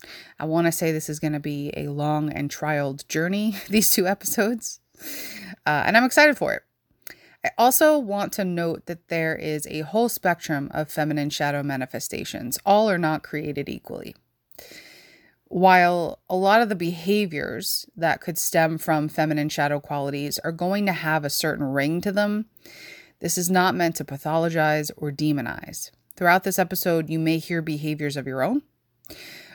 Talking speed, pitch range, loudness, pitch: 165 wpm, 150-200 Hz, -23 LUFS, 165 Hz